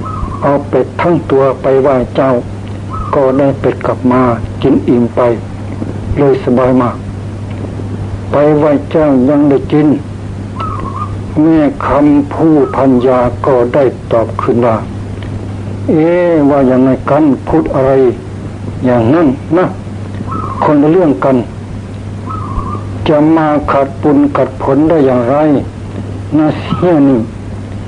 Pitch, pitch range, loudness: 120 Hz, 100-140 Hz, -11 LUFS